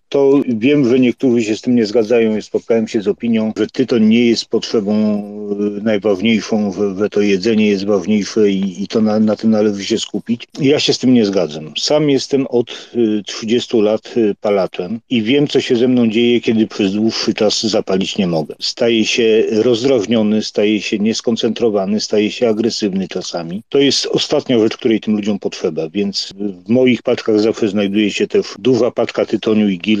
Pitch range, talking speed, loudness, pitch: 105-120 Hz, 180 wpm, -15 LUFS, 110 Hz